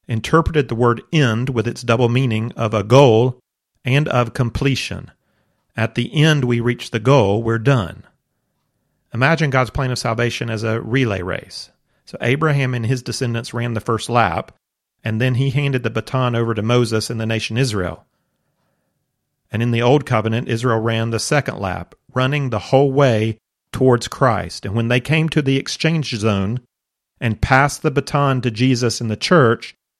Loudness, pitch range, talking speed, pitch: -18 LUFS, 115-135 Hz, 175 wpm, 120 Hz